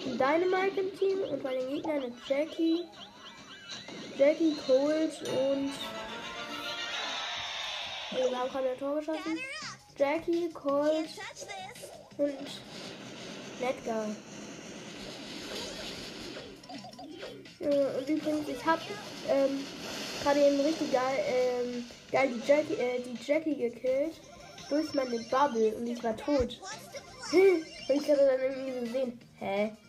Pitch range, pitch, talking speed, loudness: 255-310 Hz, 280 Hz, 110 wpm, -31 LUFS